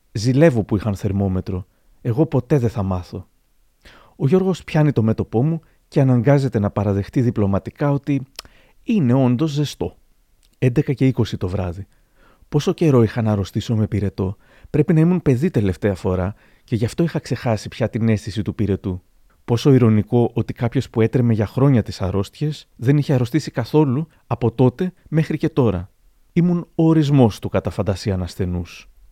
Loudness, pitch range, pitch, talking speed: -19 LUFS, 100-145 Hz, 115 Hz, 155 wpm